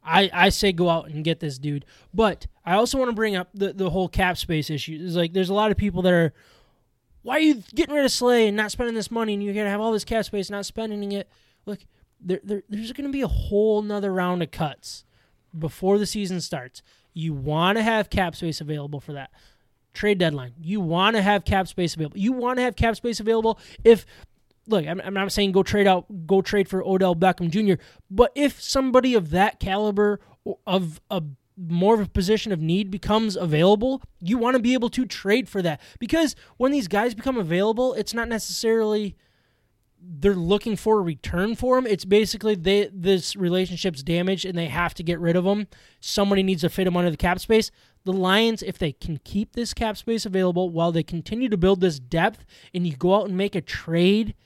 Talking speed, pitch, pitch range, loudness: 220 wpm, 195 Hz, 175-220 Hz, -23 LUFS